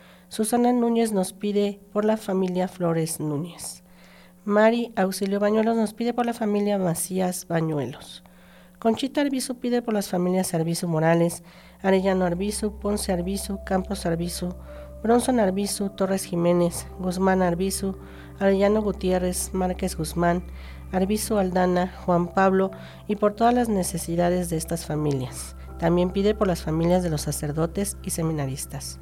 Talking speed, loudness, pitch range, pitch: 135 wpm, -24 LUFS, 170-205 Hz, 185 Hz